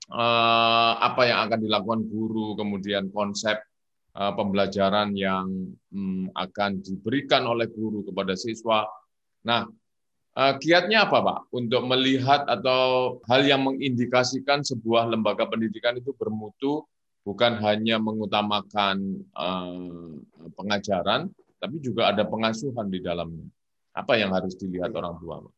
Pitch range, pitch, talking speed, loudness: 100-120 Hz, 110 Hz, 110 wpm, -24 LUFS